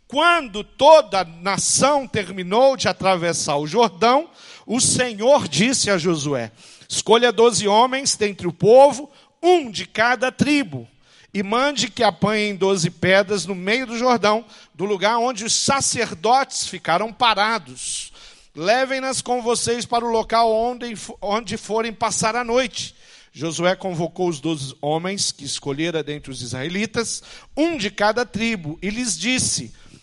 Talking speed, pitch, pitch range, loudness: 140 wpm, 220 Hz, 185-245 Hz, -19 LUFS